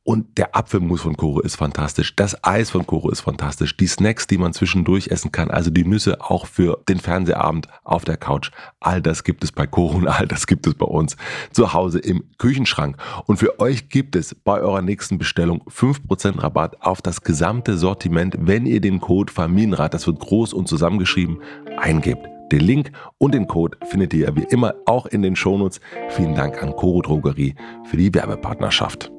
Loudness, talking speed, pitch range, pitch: -19 LUFS, 195 wpm, 80-100 Hz, 90 Hz